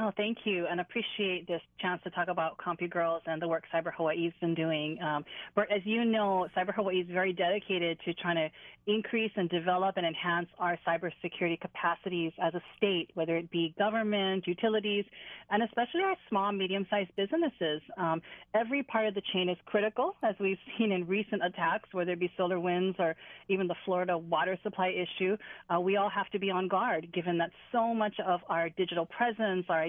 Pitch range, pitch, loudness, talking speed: 170-205 Hz, 185 Hz, -32 LUFS, 195 wpm